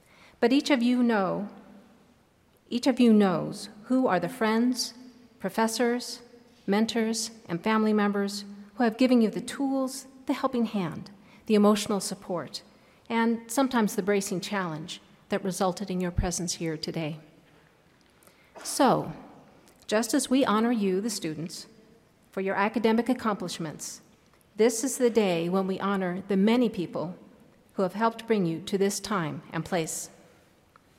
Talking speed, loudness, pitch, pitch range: 145 wpm, -27 LUFS, 210 Hz, 190-235 Hz